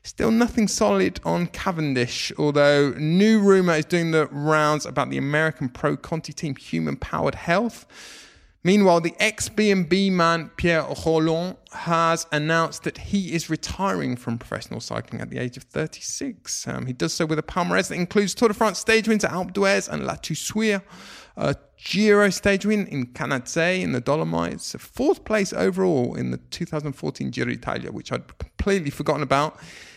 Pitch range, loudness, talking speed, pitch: 145-195 Hz, -23 LUFS, 165 wpm, 165 Hz